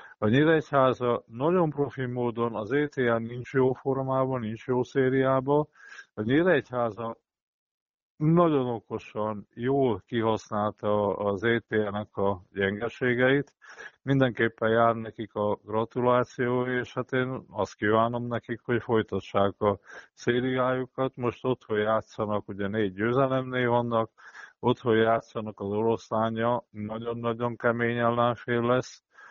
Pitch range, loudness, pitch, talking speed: 110-130 Hz, -27 LUFS, 120 Hz, 115 wpm